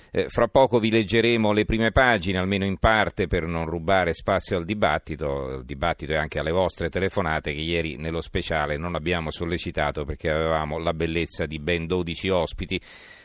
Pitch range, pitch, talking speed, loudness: 80-95 Hz, 85 Hz, 170 wpm, -24 LUFS